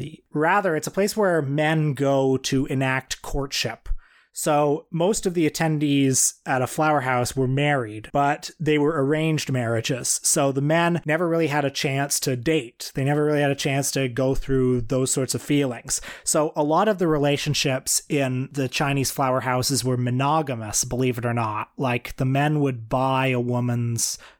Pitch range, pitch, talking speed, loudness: 130-150 Hz, 140 Hz, 180 wpm, -22 LUFS